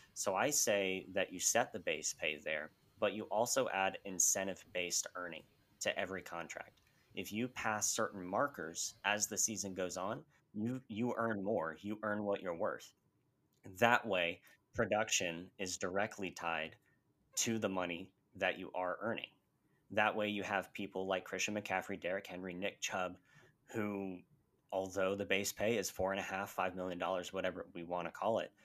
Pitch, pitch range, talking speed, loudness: 95 Hz, 95-105 Hz, 170 wpm, -38 LUFS